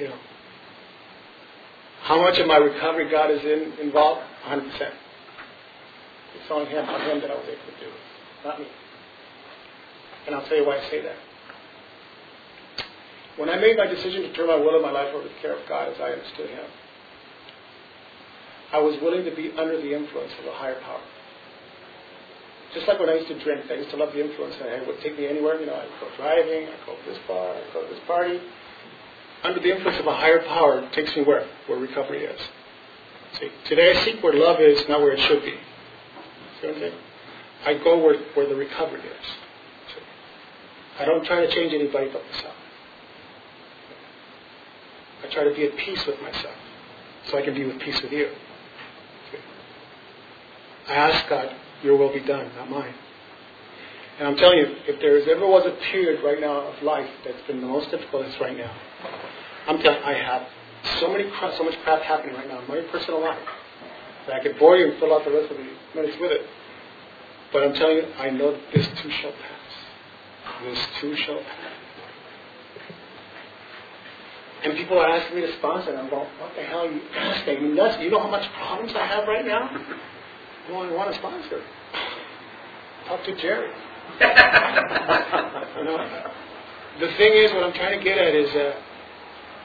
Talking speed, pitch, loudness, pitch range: 195 wpm, 160 Hz, -22 LUFS, 150-225 Hz